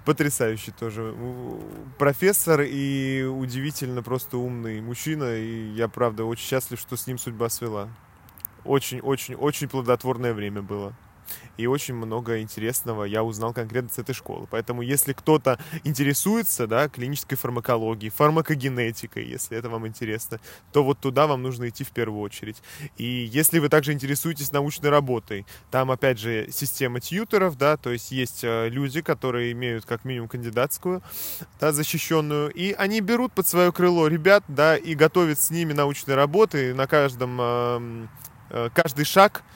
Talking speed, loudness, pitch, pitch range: 145 wpm, -24 LUFS, 130 Hz, 115-150 Hz